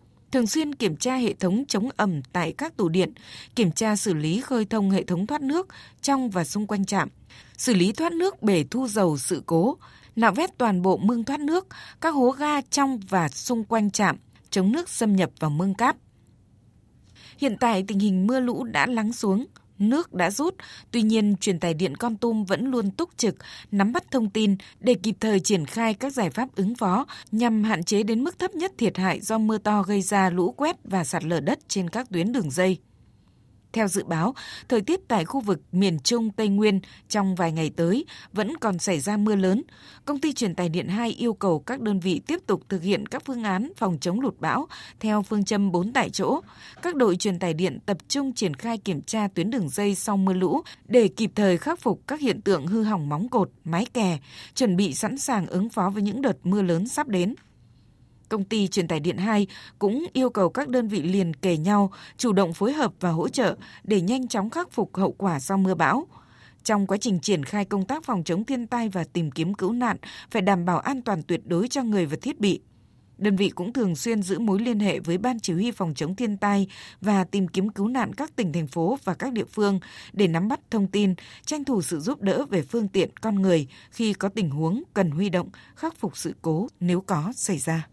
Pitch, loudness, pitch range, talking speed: 205 Hz, -25 LUFS, 185-235 Hz, 230 wpm